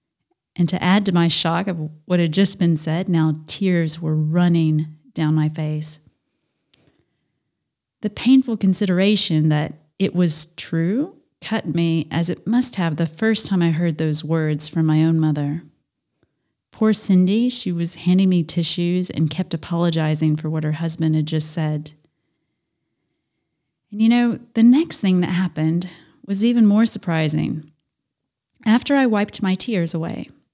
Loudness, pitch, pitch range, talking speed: -19 LUFS, 170 Hz, 155-195 Hz, 155 wpm